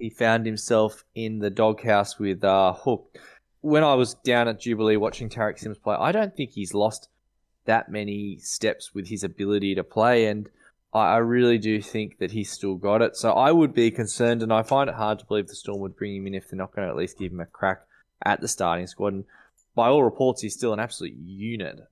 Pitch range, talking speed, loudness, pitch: 100-115 Hz, 225 wpm, -24 LUFS, 110 Hz